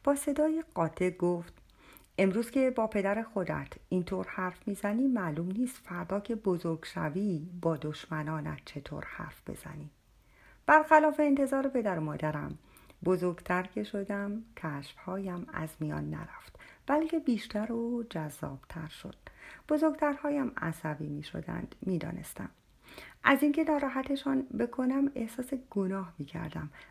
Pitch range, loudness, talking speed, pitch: 160-260 Hz, -32 LUFS, 115 wpm, 195 Hz